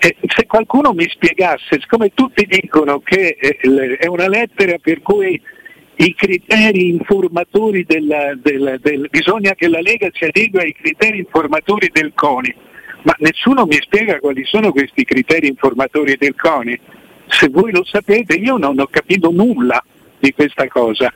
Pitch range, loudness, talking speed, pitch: 150-205 Hz, -13 LUFS, 150 wpm, 175 Hz